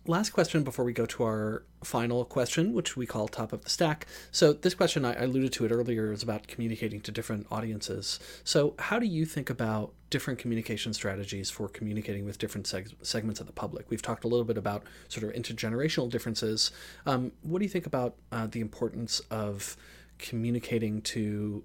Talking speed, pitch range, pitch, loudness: 190 wpm, 110-125 Hz, 115 Hz, -31 LUFS